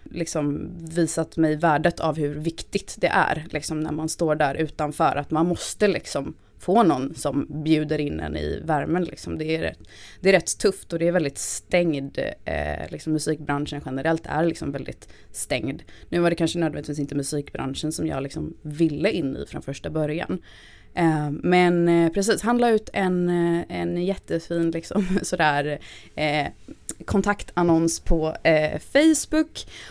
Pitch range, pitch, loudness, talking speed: 145-170 Hz, 160 Hz, -24 LUFS, 160 wpm